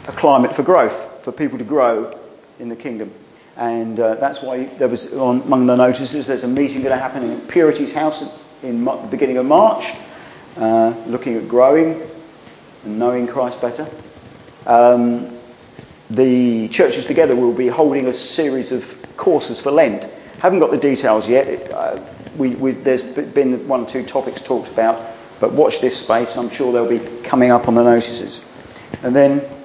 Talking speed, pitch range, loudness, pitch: 180 wpm, 120-140 Hz, -16 LUFS, 125 Hz